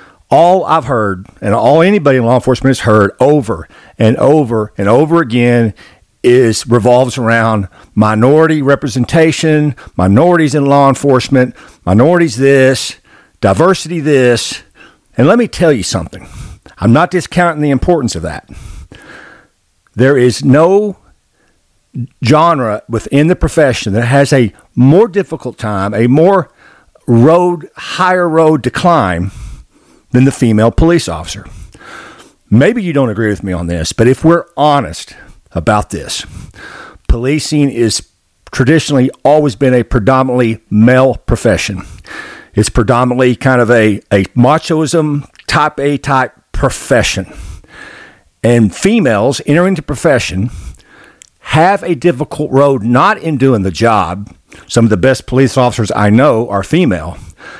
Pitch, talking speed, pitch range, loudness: 130 Hz, 130 wpm, 115-150 Hz, -11 LUFS